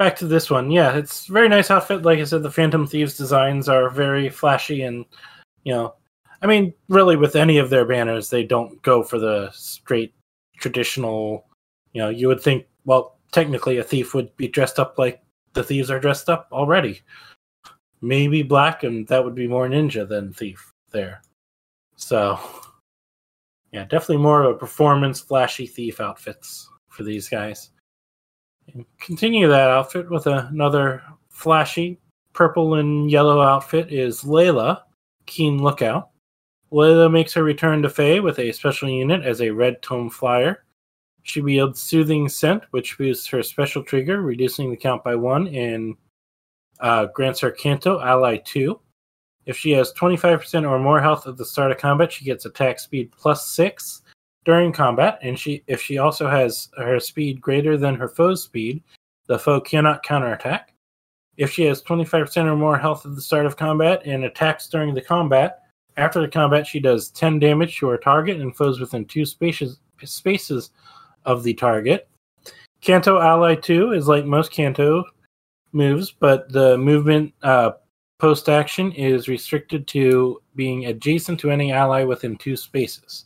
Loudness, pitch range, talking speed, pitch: -19 LUFS, 125-155 Hz, 165 wpm, 140 Hz